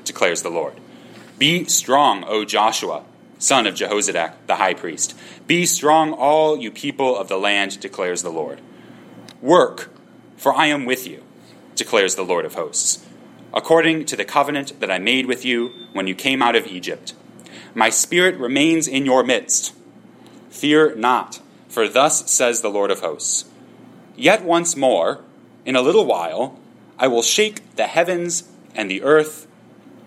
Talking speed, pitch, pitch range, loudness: 160 wpm, 145 Hz, 125-165 Hz, -18 LUFS